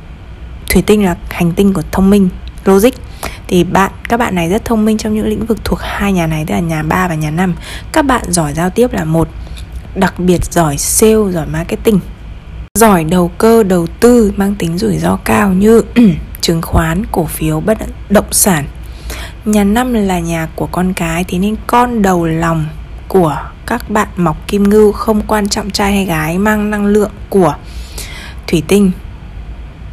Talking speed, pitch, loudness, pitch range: 185 wpm, 185 Hz, -12 LUFS, 160-210 Hz